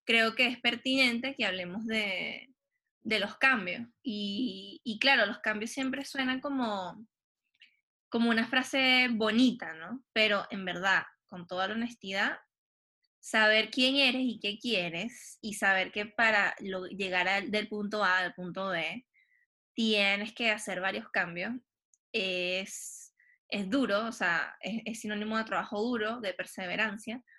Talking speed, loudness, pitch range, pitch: 145 wpm, -30 LUFS, 200-250 Hz, 220 Hz